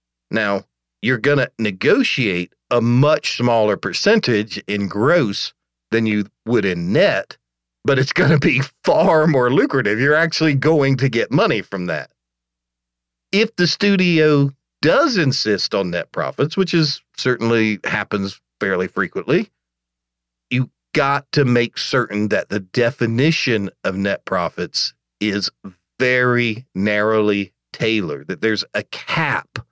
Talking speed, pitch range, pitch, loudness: 130 wpm, 100-140 Hz, 115 Hz, -18 LUFS